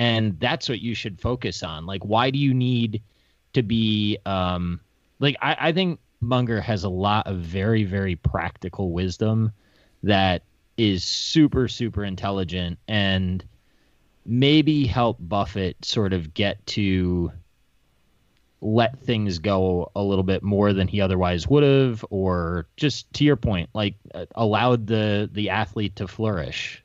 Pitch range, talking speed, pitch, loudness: 95-115 Hz, 145 wpm, 105 Hz, -23 LUFS